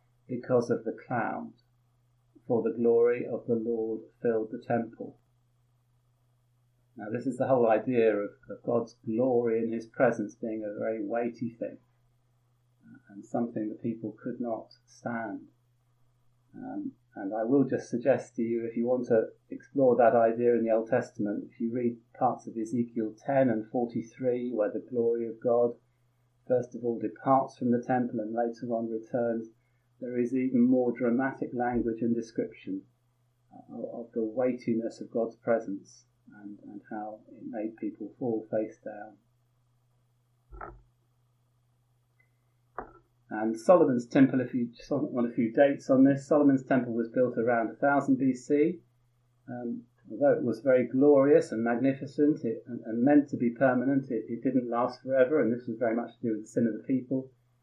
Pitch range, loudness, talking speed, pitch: 115-125 Hz, -29 LUFS, 165 wpm, 120 Hz